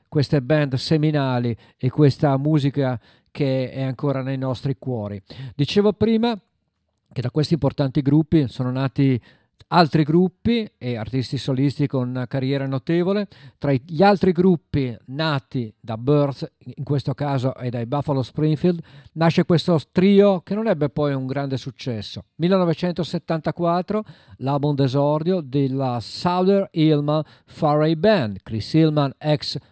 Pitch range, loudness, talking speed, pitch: 130-165 Hz, -21 LUFS, 130 wpm, 145 Hz